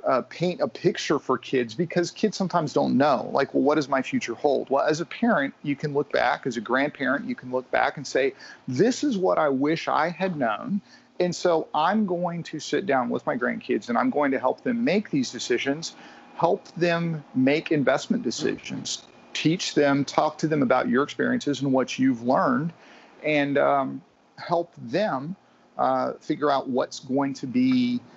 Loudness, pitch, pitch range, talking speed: -25 LUFS, 155 Hz, 140-190 Hz, 190 wpm